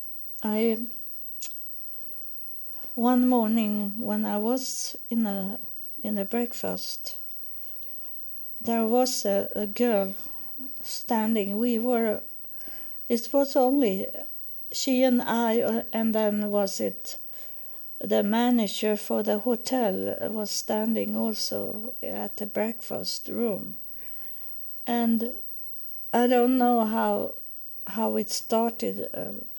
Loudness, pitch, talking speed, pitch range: -27 LUFS, 230 Hz, 105 wpm, 210-245 Hz